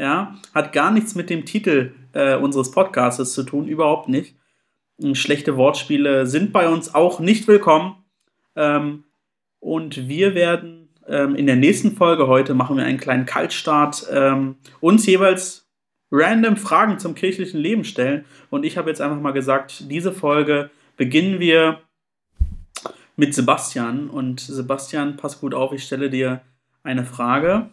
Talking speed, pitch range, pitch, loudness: 150 wpm, 135-175 Hz, 150 Hz, -19 LUFS